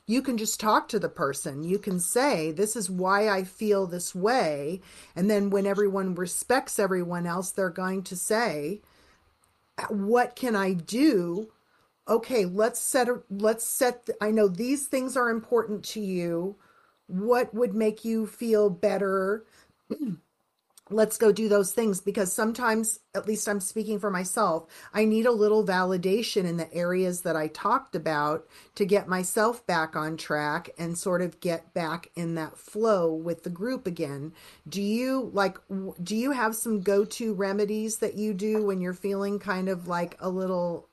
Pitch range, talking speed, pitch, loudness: 180-220 Hz, 170 wpm, 200 Hz, -27 LUFS